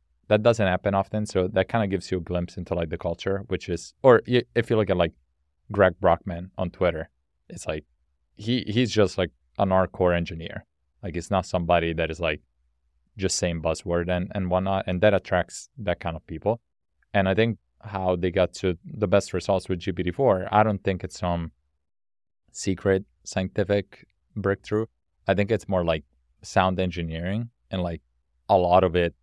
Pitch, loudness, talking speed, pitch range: 90 Hz, -25 LUFS, 185 wpm, 85-100 Hz